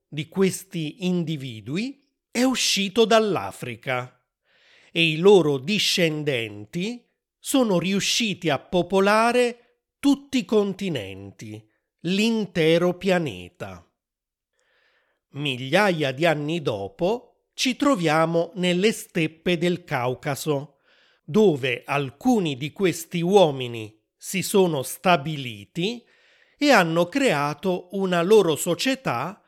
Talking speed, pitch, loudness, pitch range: 90 wpm, 175 Hz, -22 LUFS, 150-215 Hz